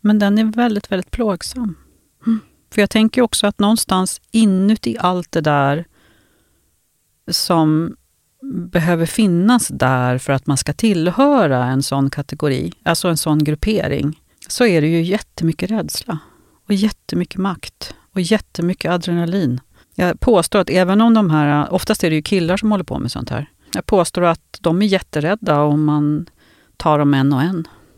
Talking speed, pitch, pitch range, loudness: 165 wpm, 175 Hz, 150-205 Hz, -17 LUFS